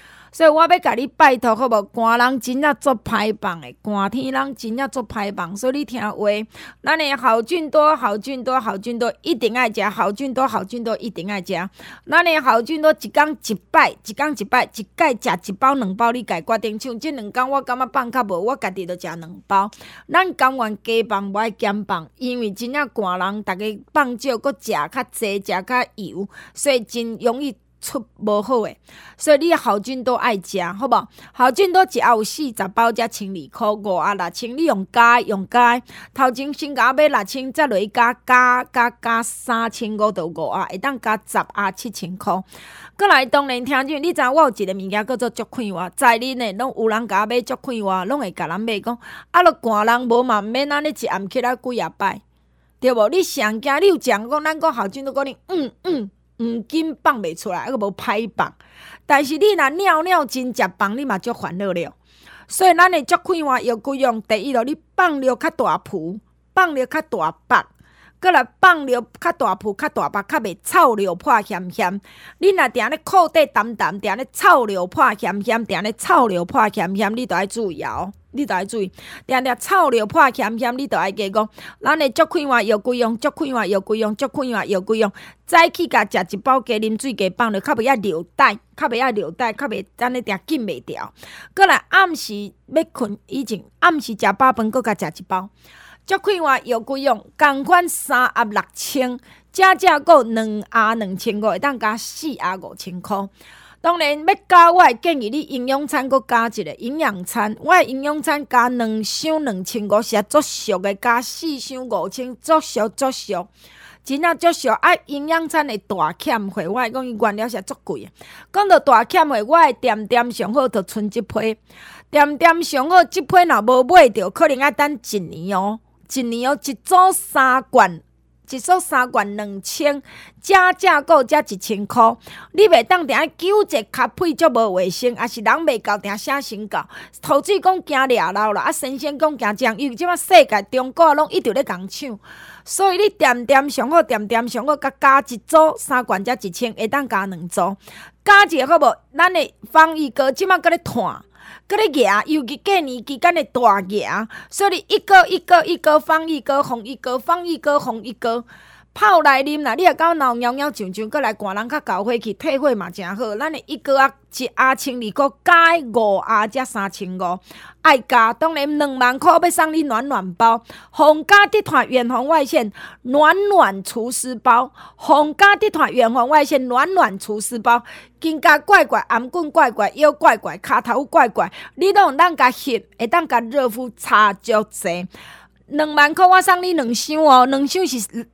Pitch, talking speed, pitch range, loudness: 250 Hz, 265 characters per minute, 215-300 Hz, -17 LUFS